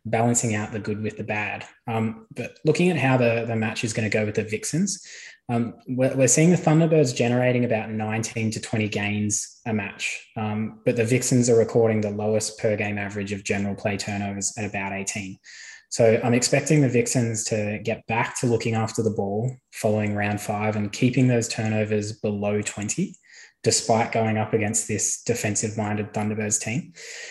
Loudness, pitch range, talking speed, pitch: -24 LUFS, 105-120 Hz, 185 wpm, 110 Hz